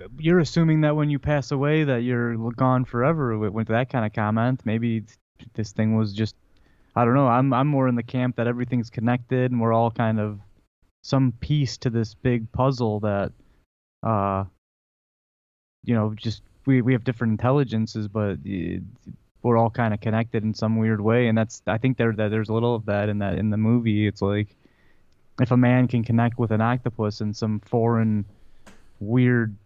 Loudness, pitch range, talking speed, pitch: -23 LUFS, 105-125 Hz, 185 wpm, 115 Hz